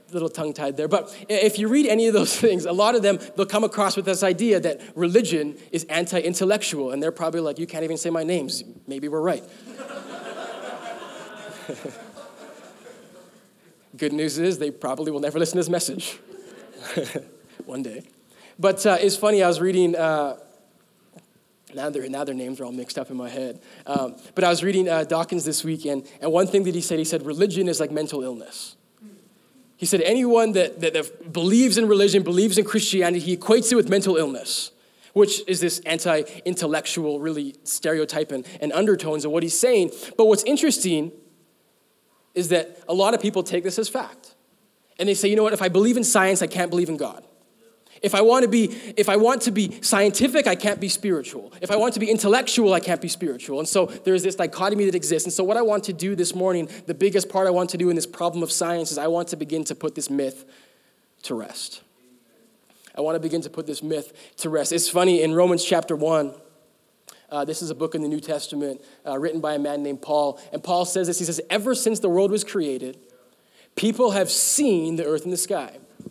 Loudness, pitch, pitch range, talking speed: -22 LUFS, 175 Hz, 155-205 Hz, 215 wpm